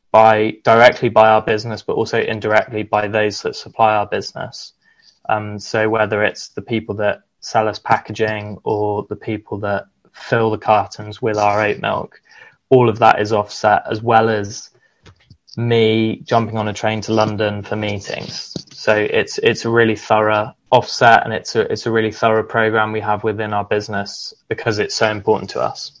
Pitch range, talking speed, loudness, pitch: 105-110 Hz, 180 wpm, -17 LUFS, 110 Hz